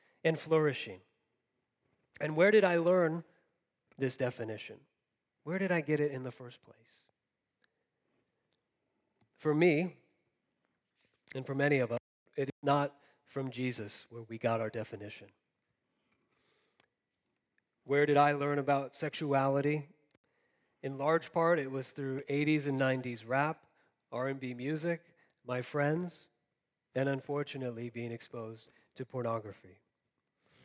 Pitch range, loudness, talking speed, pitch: 120-150 Hz, -33 LUFS, 115 wpm, 135 Hz